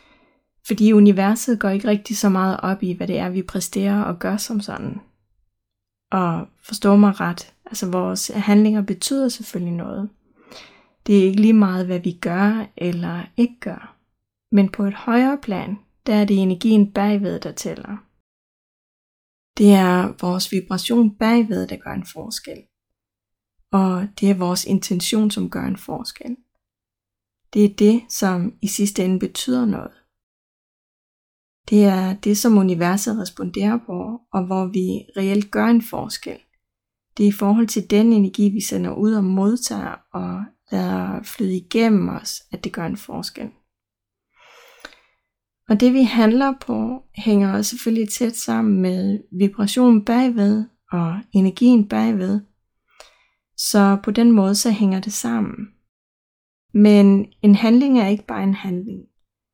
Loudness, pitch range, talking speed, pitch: -19 LUFS, 190-220 Hz, 145 wpm, 205 Hz